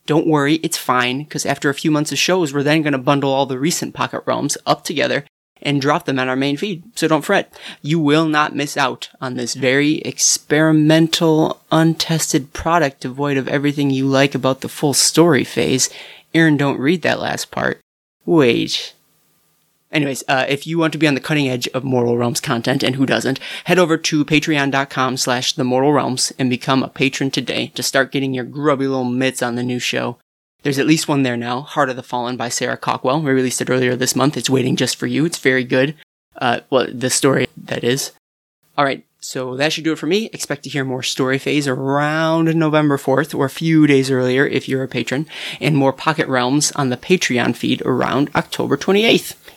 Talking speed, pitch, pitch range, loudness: 205 wpm, 140 Hz, 130-155 Hz, -17 LUFS